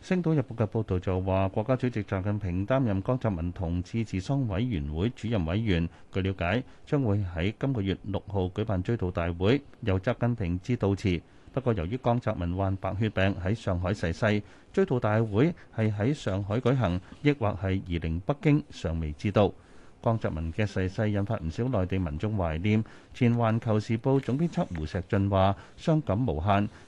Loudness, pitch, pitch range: -29 LUFS, 105 Hz, 95-120 Hz